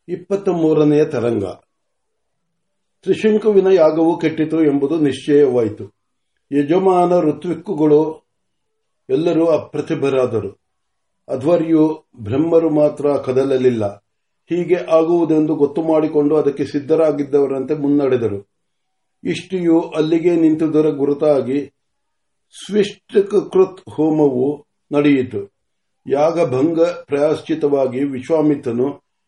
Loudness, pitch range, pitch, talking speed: -16 LUFS, 145-170 Hz, 155 Hz, 65 wpm